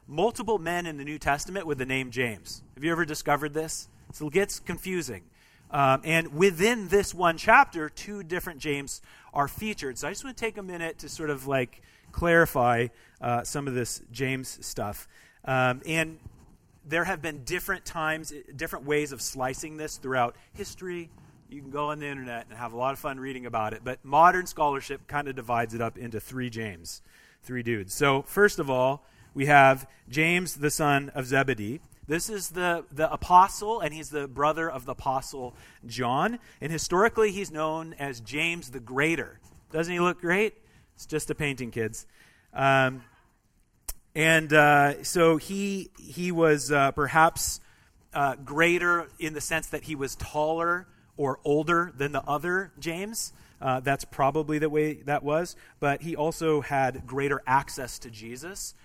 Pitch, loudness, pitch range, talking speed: 145 Hz, -27 LUFS, 130-165 Hz, 175 wpm